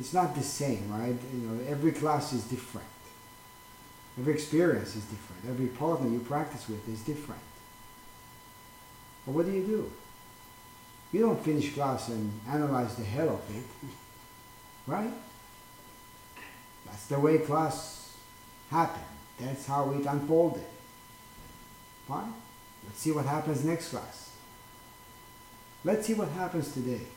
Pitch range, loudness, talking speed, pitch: 110-150 Hz, -32 LUFS, 135 wpm, 125 Hz